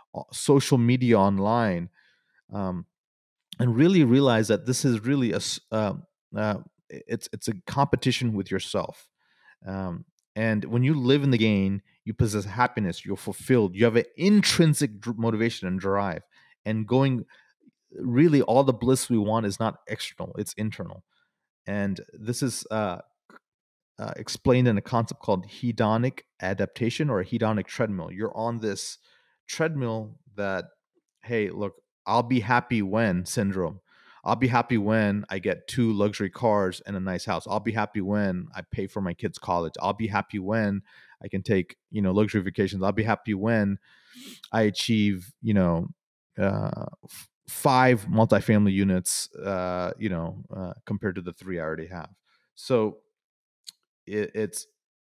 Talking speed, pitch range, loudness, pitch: 155 wpm, 100-125 Hz, -26 LUFS, 110 Hz